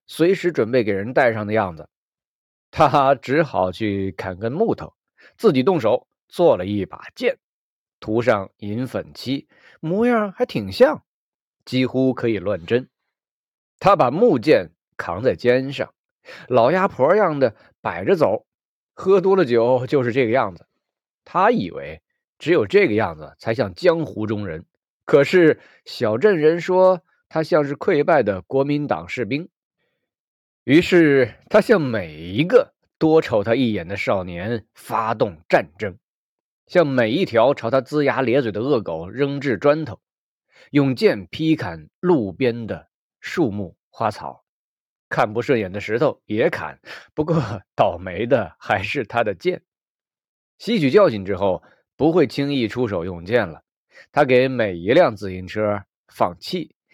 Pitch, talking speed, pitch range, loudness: 130 Hz, 205 characters per minute, 105-155 Hz, -20 LUFS